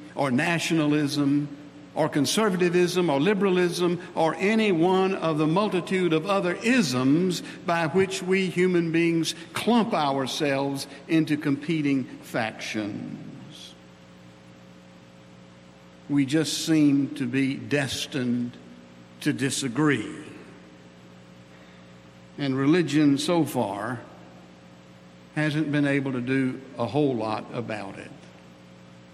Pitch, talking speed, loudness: 140 Hz, 95 wpm, -25 LUFS